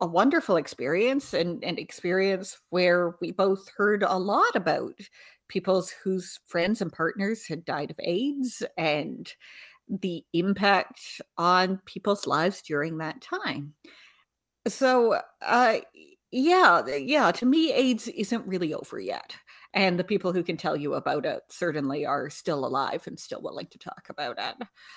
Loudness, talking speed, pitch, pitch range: -26 LUFS, 150 wpm, 195 Hz, 175-245 Hz